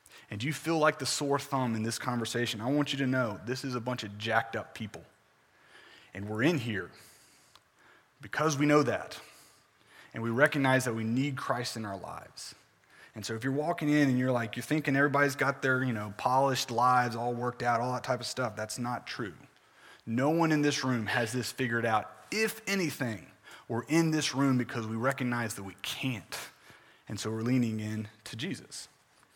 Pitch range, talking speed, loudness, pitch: 115-140 Hz, 200 wpm, -31 LUFS, 125 Hz